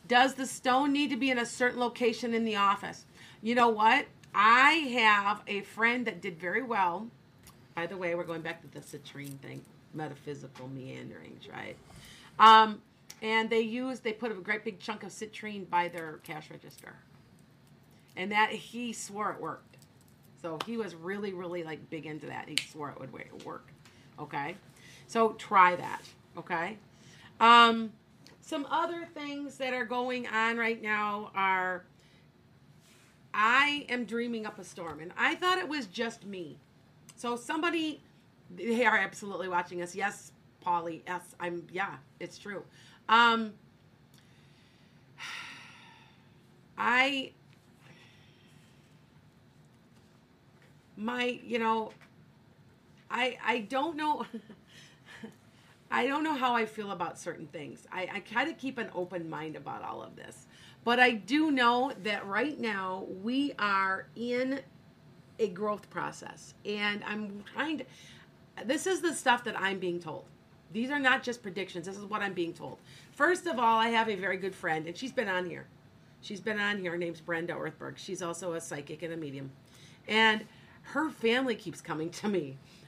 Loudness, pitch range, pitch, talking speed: -30 LUFS, 175-240 Hz, 210 Hz, 160 wpm